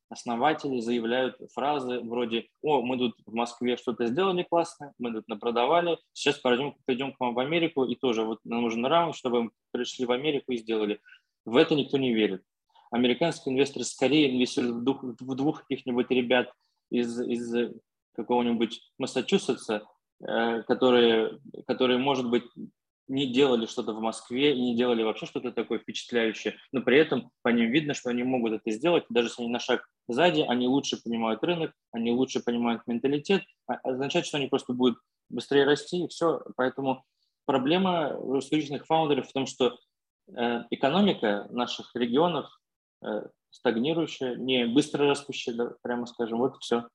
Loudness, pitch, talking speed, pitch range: -28 LUFS, 125 Hz, 155 wpm, 120-140 Hz